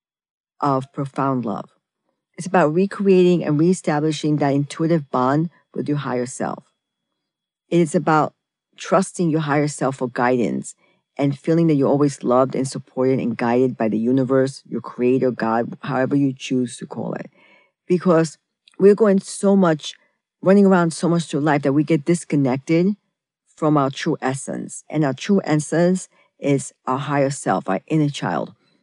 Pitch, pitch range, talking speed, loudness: 145 Hz, 130-170 Hz, 160 wpm, -20 LUFS